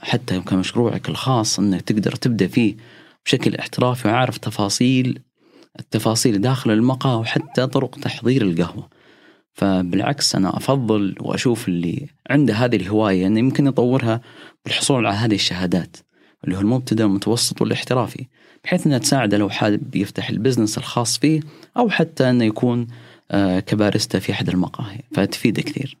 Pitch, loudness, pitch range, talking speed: 120 Hz, -19 LUFS, 105-130 Hz, 135 wpm